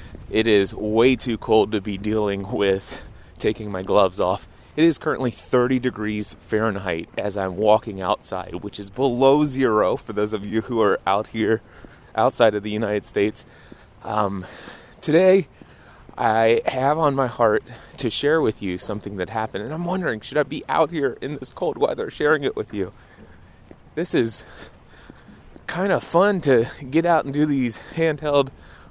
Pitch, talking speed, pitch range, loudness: 110 Hz, 170 wpm, 100-130 Hz, -22 LUFS